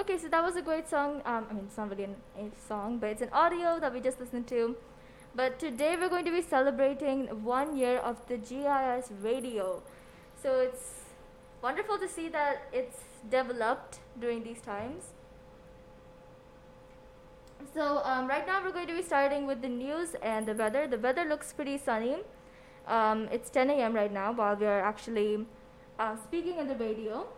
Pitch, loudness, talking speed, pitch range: 255 Hz, -32 LUFS, 180 wpm, 225-295 Hz